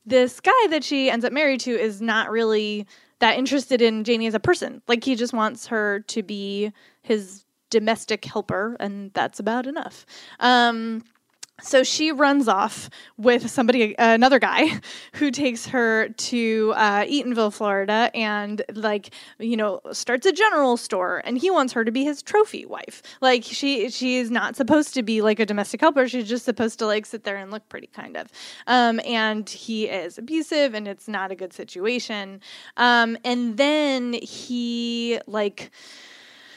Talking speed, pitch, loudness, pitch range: 175 wpm, 235 Hz, -22 LUFS, 215-255 Hz